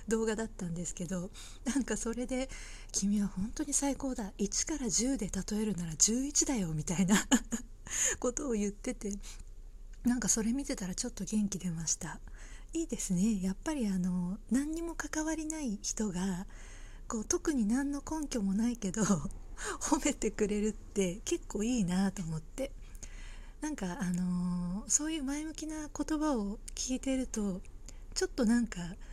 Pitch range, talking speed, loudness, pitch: 195-270 Hz, 295 characters per minute, -34 LUFS, 225 Hz